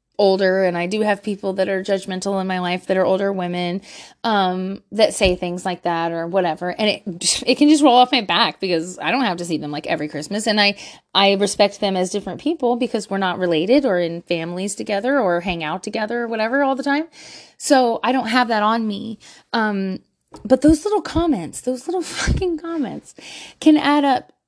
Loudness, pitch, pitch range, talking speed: -19 LUFS, 205 Hz, 185-250 Hz, 215 wpm